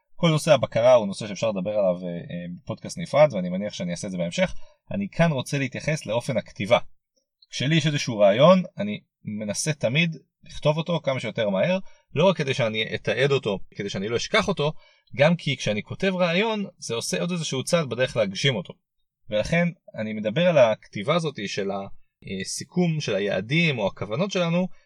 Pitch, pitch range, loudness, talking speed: 170 Hz, 135-185 Hz, -24 LUFS, 175 wpm